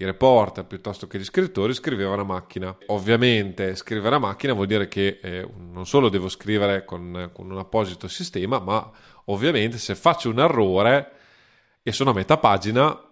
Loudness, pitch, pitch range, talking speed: -22 LUFS, 100 Hz, 95-110 Hz, 170 wpm